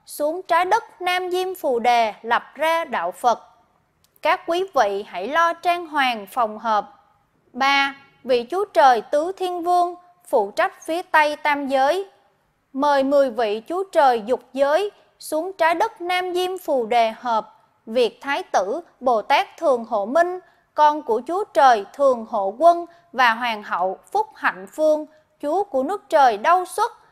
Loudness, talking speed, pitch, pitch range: -21 LUFS, 165 wpm, 305 Hz, 245-355 Hz